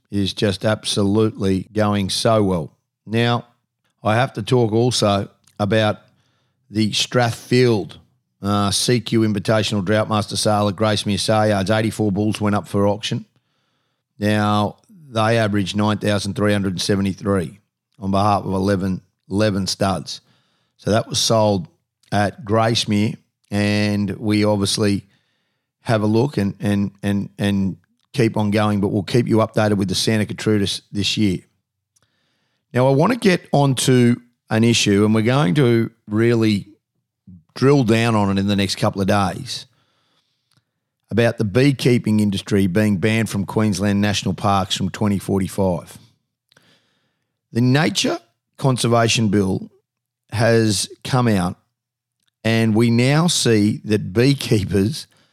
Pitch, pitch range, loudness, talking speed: 110 Hz, 100-120 Hz, -19 LUFS, 130 wpm